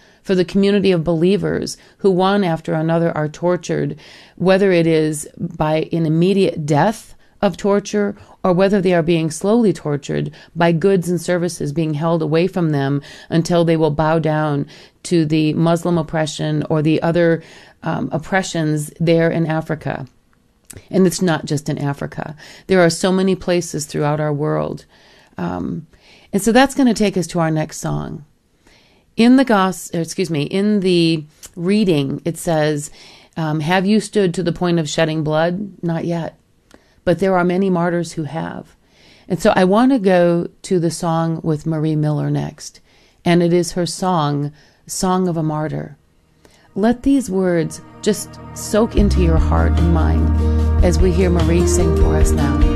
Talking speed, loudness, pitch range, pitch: 170 wpm, -17 LUFS, 150-185 Hz, 165 Hz